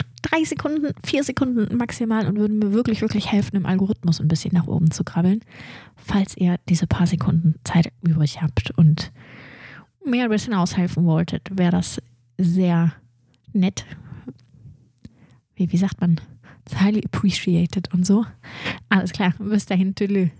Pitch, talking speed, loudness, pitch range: 180 Hz, 145 wpm, -21 LUFS, 160-205 Hz